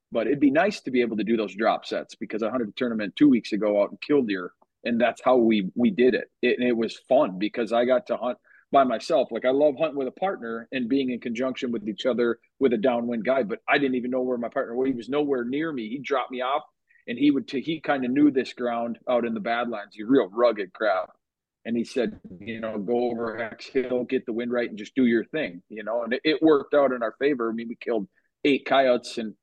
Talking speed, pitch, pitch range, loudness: 270 wpm, 125 Hz, 115-135 Hz, -25 LUFS